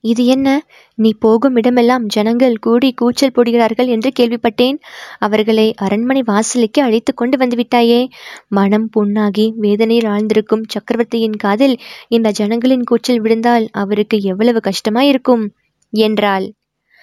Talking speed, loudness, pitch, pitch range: 110 wpm, -14 LUFS, 230 Hz, 215-245 Hz